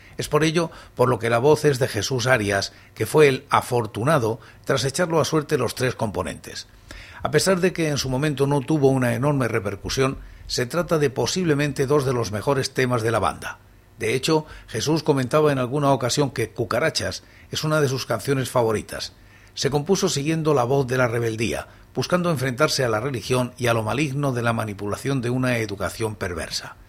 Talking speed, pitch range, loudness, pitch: 190 wpm, 115-150 Hz, -22 LUFS, 130 Hz